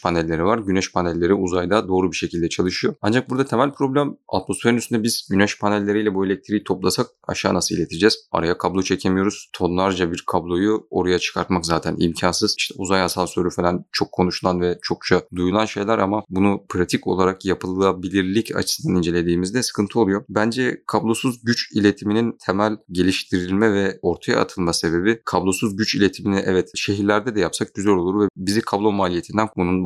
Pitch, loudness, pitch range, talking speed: 95 Hz, -20 LUFS, 90-105 Hz, 155 wpm